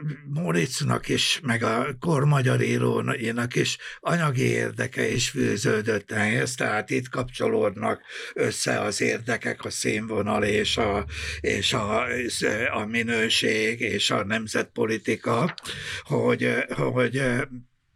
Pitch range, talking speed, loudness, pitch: 110-135 Hz, 110 wpm, -25 LUFS, 120 Hz